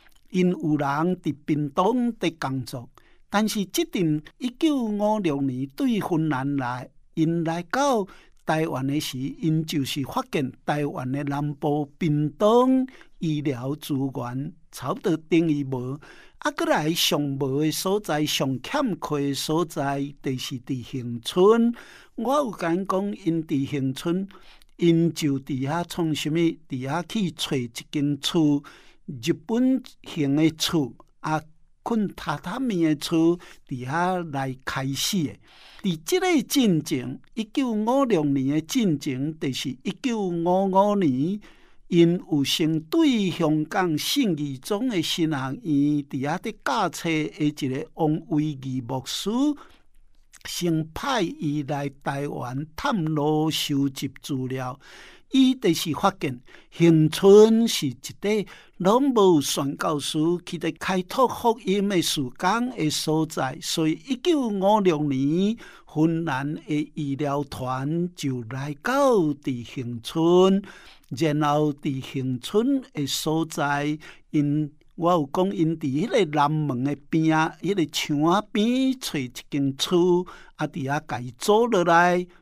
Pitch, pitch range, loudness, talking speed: 160 Hz, 145-190 Hz, -24 LUFS, 185 characters per minute